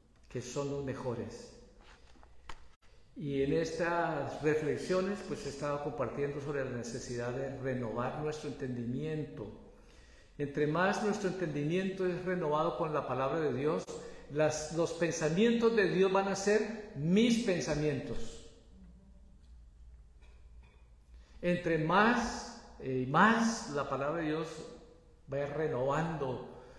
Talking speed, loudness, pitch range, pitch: 110 wpm, -33 LUFS, 125-170 Hz, 150 Hz